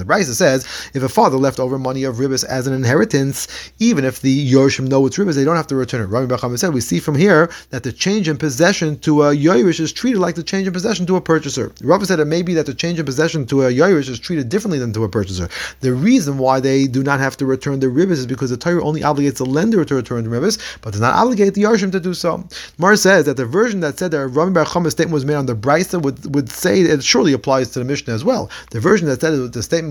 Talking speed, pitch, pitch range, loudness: 280 wpm, 145 Hz, 130-170 Hz, -16 LUFS